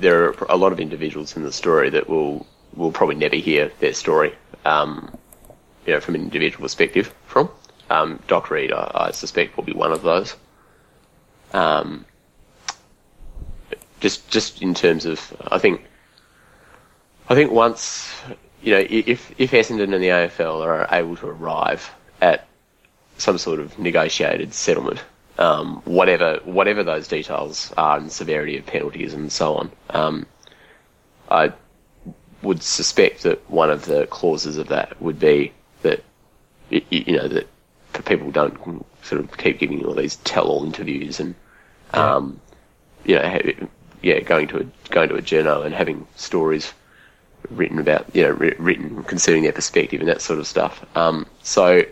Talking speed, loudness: 155 wpm, -20 LUFS